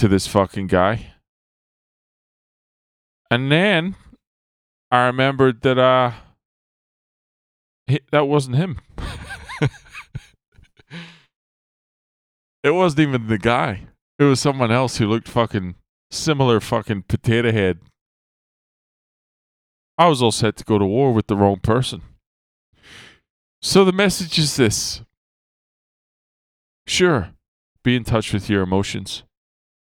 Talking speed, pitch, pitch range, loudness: 105 wpm, 115 Hz, 95-135 Hz, -19 LUFS